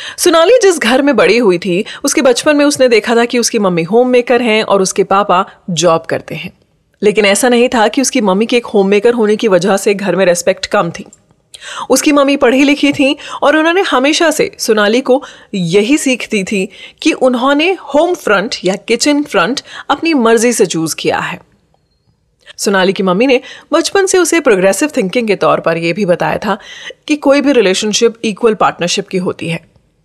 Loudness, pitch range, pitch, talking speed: -11 LUFS, 195-280 Hz, 235 Hz, 195 wpm